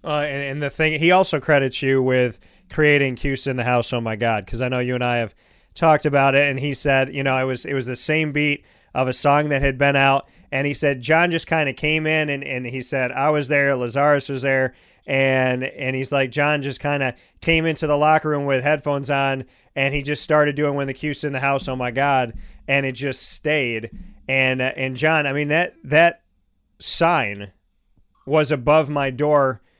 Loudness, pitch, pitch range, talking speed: -20 LUFS, 140 Hz, 130-150 Hz, 230 wpm